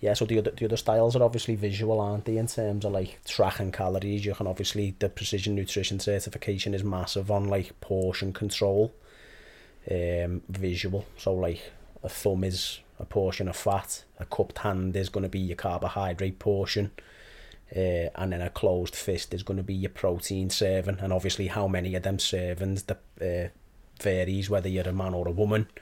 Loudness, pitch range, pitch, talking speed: -29 LUFS, 95-105 Hz, 95 Hz, 190 wpm